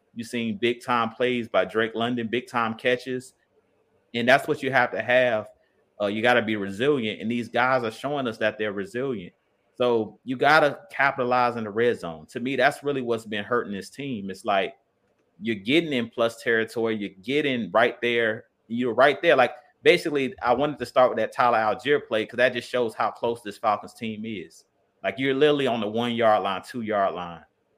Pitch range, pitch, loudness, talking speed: 110-125 Hz, 120 Hz, -24 LUFS, 210 wpm